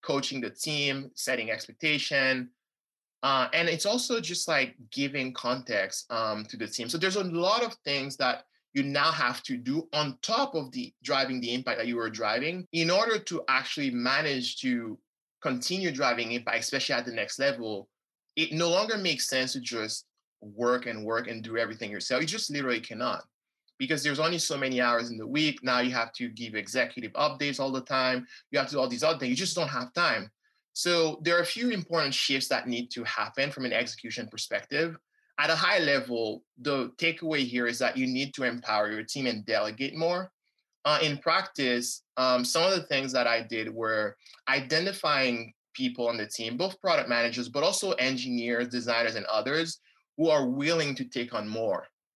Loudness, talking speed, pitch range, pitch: -29 LUFS, 195 wpm, 120-165 Hz, 135 Hz